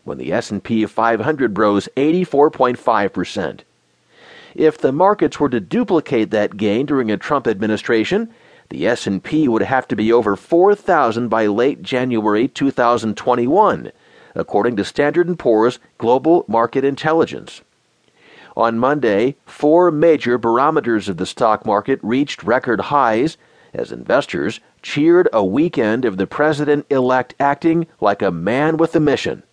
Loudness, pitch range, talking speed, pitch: -17 LUFS, 110-155 Hz, 130 wpm, 130 Hz